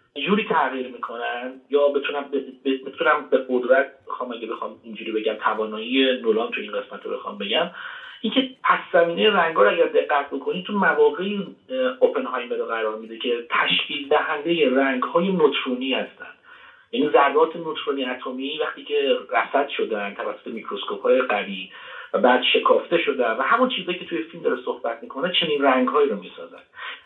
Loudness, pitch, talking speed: -22 LUFS, 185 Hz, 160 wpm